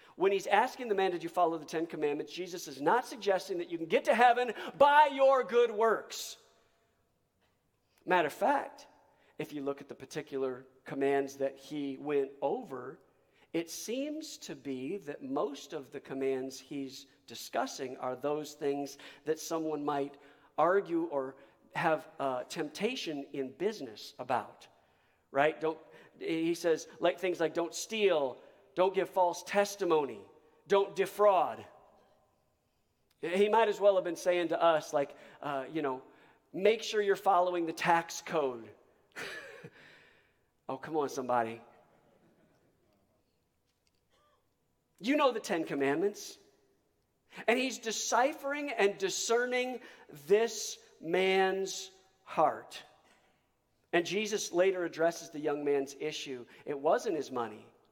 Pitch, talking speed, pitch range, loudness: 170 Hz, 135 wpm, 140-210 Hz, -32 LUFS